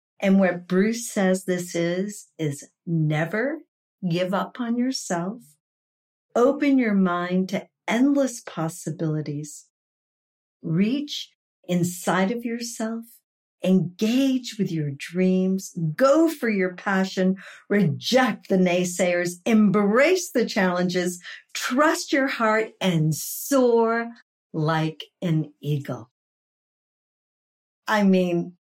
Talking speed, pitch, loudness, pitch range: 95 wpm, 190 Hz, -23 LUFS, 175-230 Hz